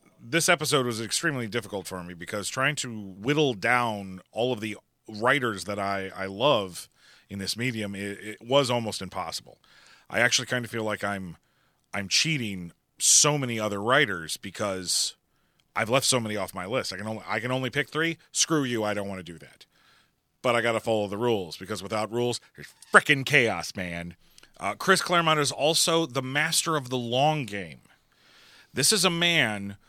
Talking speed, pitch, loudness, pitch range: 185 wpm, 115 Hz, -25 LUFS, 100-140 Hz